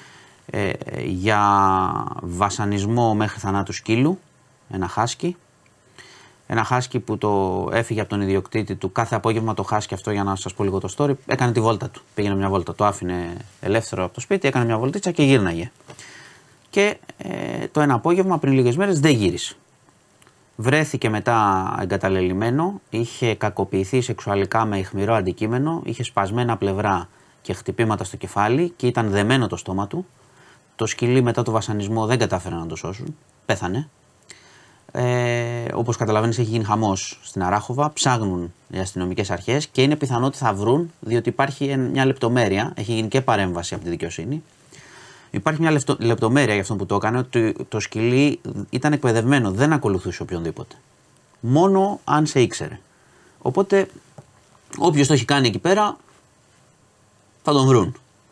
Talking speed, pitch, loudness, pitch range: 155 wpm, 115 Hz, -21 LUFS, 100-135 Hz